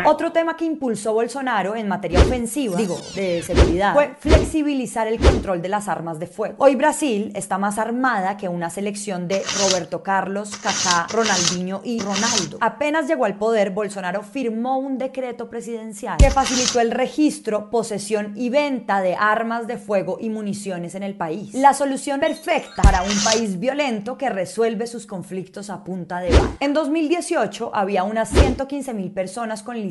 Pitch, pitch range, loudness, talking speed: 220 Hz, 195-255 Hz, -21 LUFS, 165 wpm